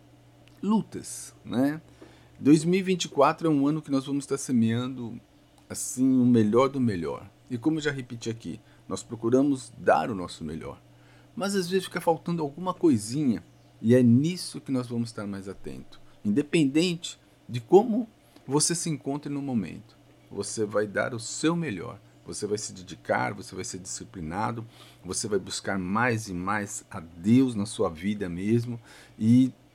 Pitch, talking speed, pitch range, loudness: 120 Hz, 160 wpm, 100-145 Hz, -27 LUFS